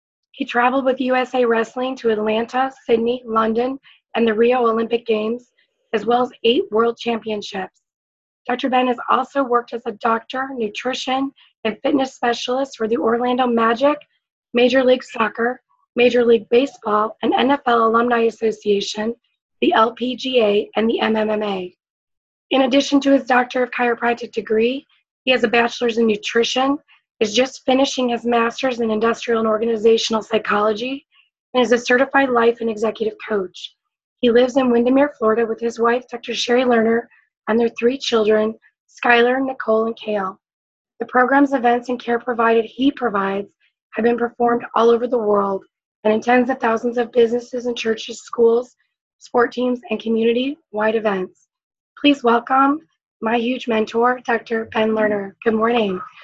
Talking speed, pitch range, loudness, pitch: 155 wpm, 225-255 Hz, -19 LUFS, 235 Hz